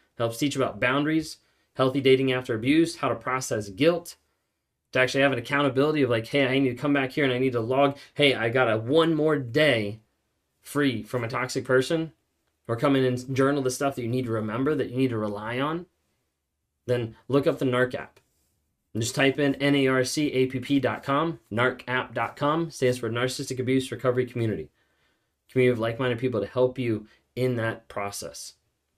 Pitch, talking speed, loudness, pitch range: 130 Hz, 190 wpm, -25 LUFS, 120-140 Hz